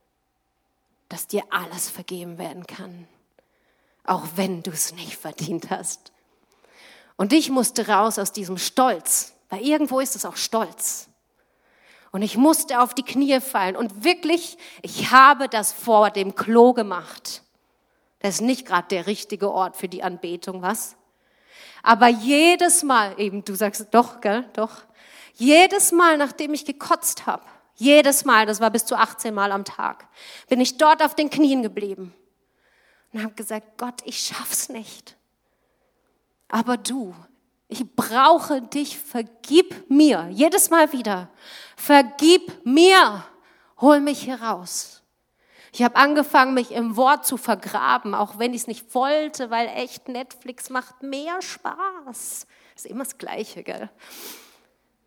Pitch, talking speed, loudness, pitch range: 240 Hz, 145 wpm, -20 LUFS, 205-280 Hz